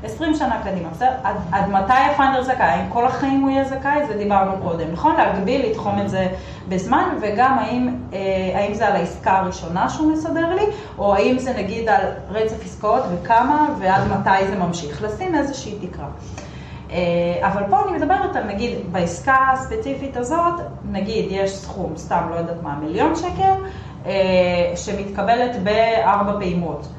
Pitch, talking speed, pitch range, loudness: 205 Hz, 150 wpm, 190-265 Hz, -20 LUFS